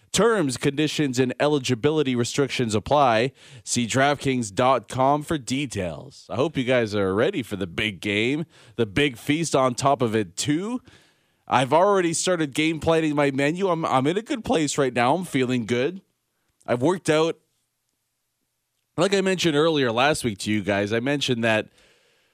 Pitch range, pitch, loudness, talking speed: 120-155 Hz, 135 Hz, -23 LUFS, 165 wpm